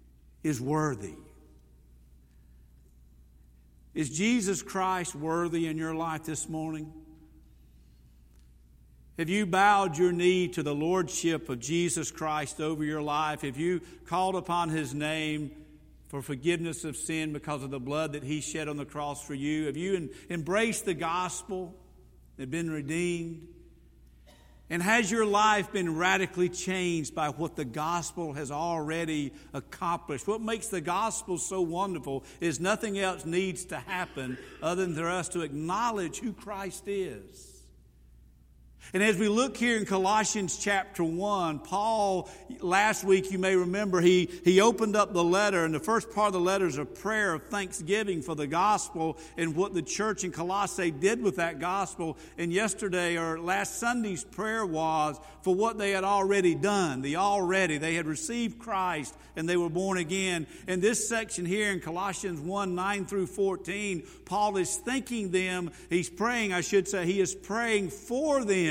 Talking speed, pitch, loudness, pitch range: 160 wpm, 175 Hz, -29 LUFS, 155-195 Hz